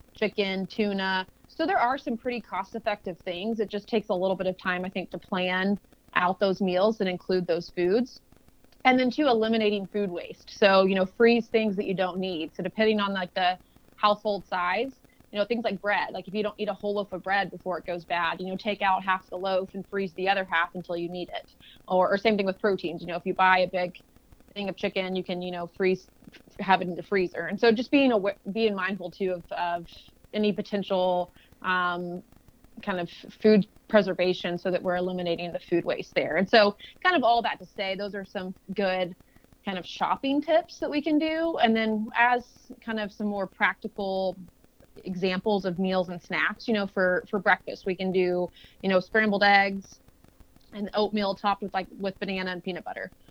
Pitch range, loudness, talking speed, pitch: 185-210 Hz, -27 LUFS, 215 wpm, 195 Hz